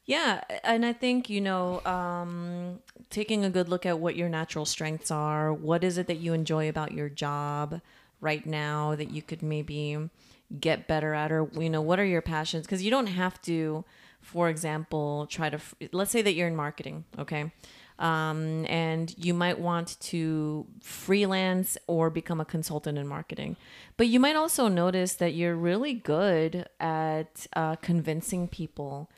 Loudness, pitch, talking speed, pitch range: -29 LUFS, 165 Hz, 175 wpm, 155-180 Hz